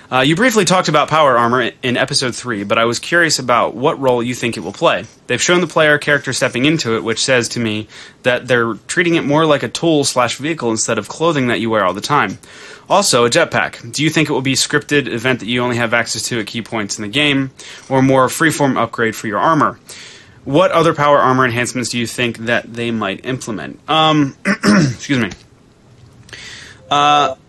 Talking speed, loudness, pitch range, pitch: 220 wpm, -15 LUFS, 115-150 Hz, 130 Hz